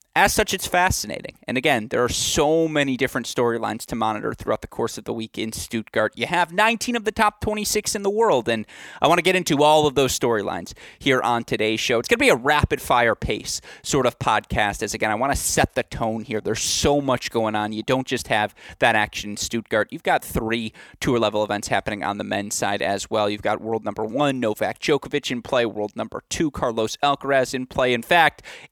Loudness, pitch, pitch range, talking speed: -22 LUFS, 120 Hz, 110-145 Hz, 230 wpm